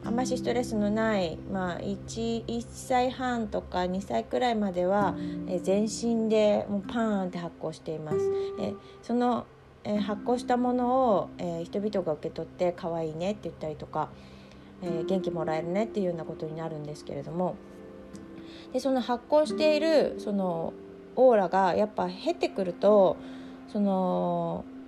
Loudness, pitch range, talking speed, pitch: -29 LUFS, 155-215 Hz, 305 characters per minute, 185 Hz